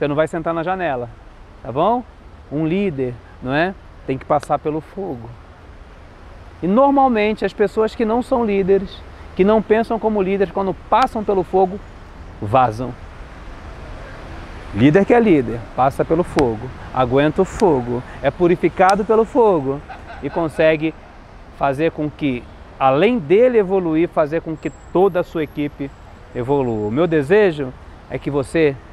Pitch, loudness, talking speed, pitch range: 155 Hz, -18 LUFS, 145 wpm, 120-195 Hz